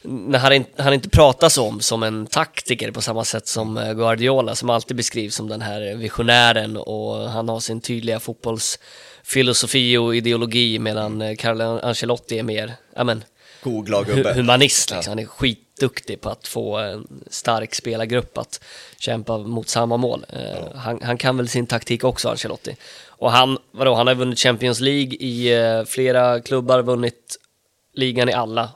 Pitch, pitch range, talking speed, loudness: 120 Hz, 115-125 Hz, 160 wpm, -19 LUFS